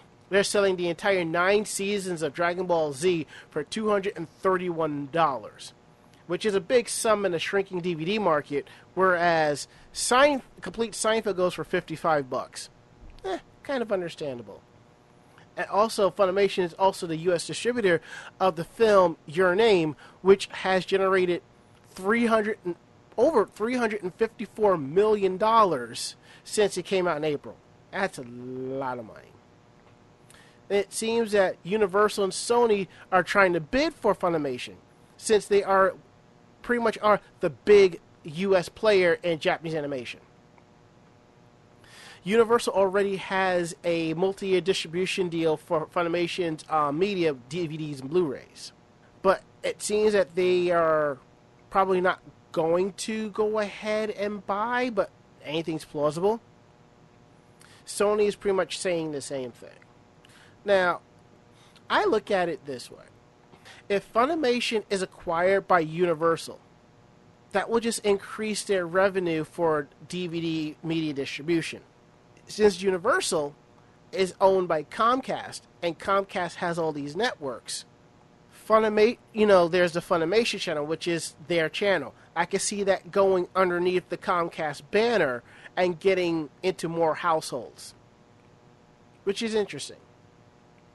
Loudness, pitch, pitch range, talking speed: -26 LUFS, 180 Hz, 160-200 Hz, 125 wpm